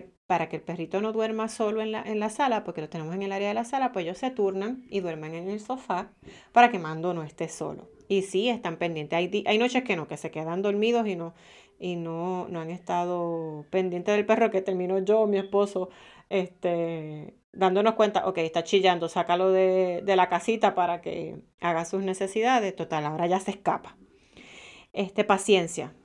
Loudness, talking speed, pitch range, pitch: -27 LUFS, 205 wpm, 170-210 Hz, 185 Hz